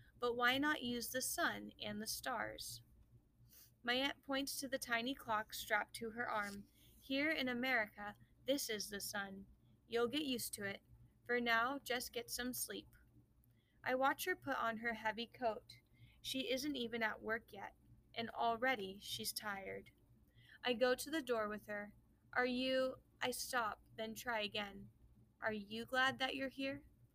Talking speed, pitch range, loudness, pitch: 170 wpm, 200-255 Hz, -41 LUFS, 230 Hz